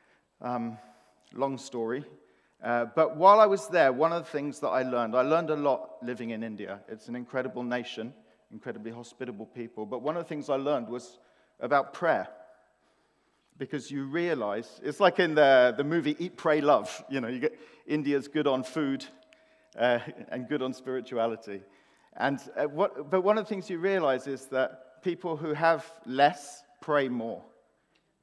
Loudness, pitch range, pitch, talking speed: -28 LUFS, 125-160 Hz, 140 Hz, 175 wpm